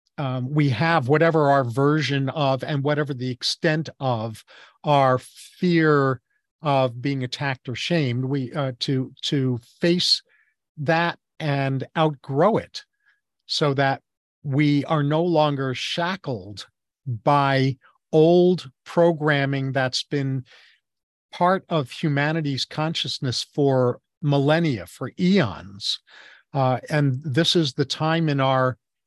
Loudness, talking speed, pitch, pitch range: -22 LUFS, 115 wpm, 140 Hz, 130-160 Hz